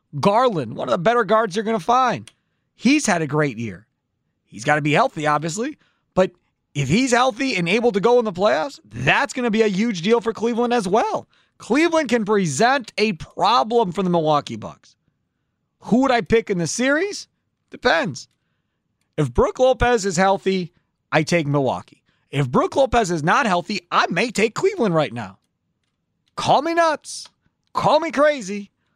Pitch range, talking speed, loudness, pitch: 165-245 Hz, 180 wpm, -19 LUFS, 215 Hz